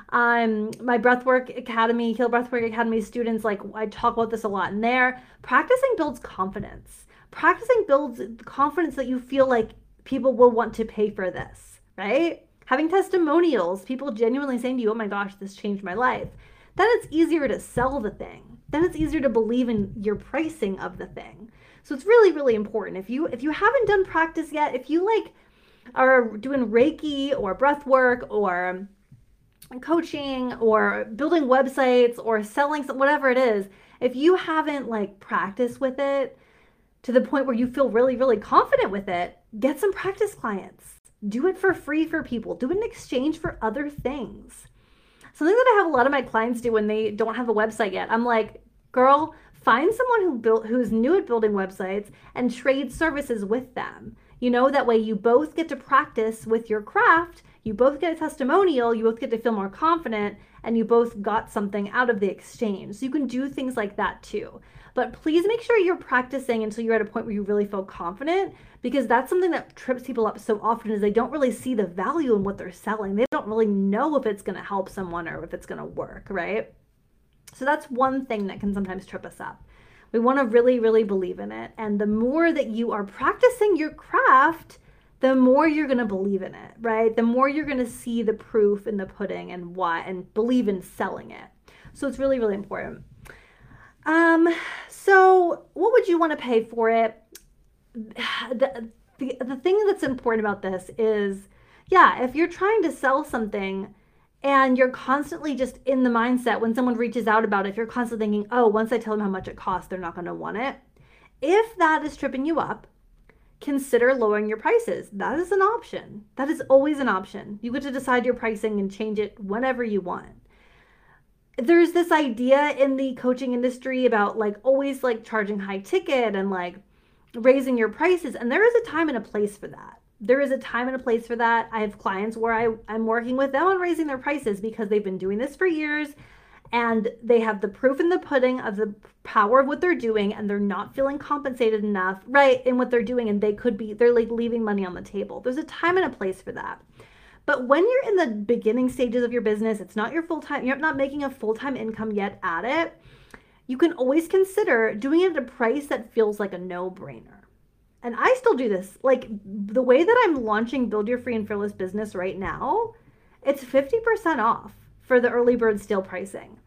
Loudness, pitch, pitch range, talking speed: -23 LUFS, 245 Hz, 215-280 Hz, 205 wpm